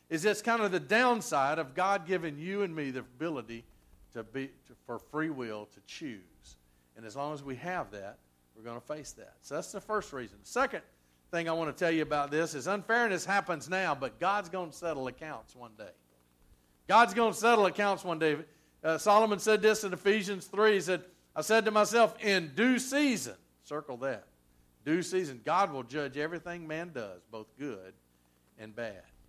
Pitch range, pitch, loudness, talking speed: 120-200 Hz, 160 Hz, -31 LUFS, 200 wpm